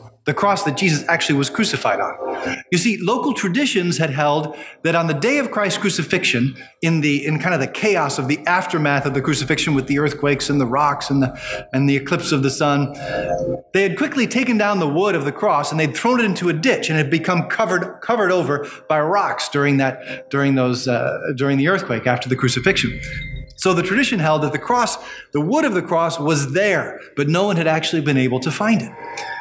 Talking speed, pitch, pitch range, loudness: 220 wpm, 155 Hz, 140-190 Hz, -19 LUFS